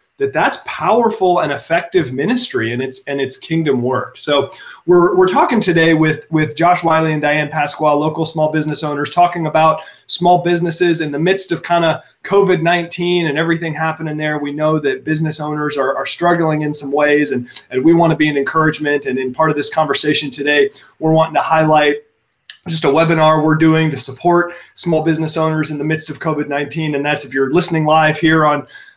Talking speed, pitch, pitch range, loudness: 200 wpm, 155 Hz, 150-170 Hz, -15 LUFS